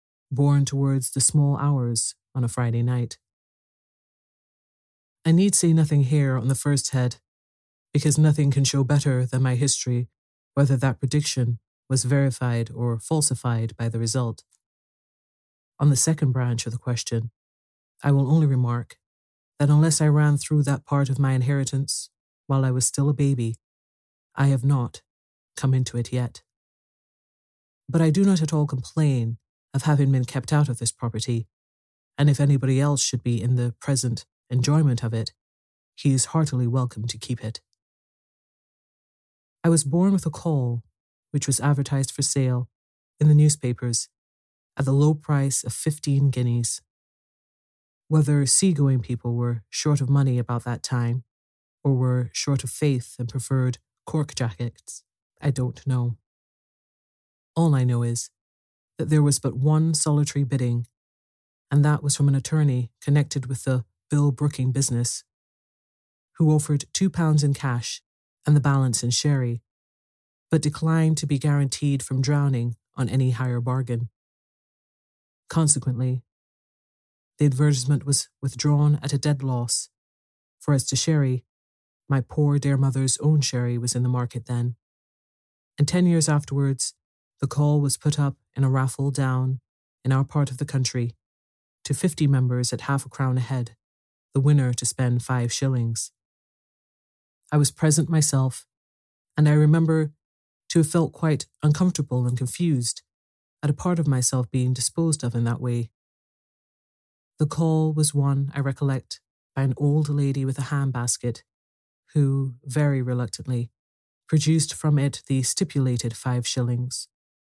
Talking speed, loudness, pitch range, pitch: 150 wpm, -23 LUFS, 120-145 Hz, 130 Hz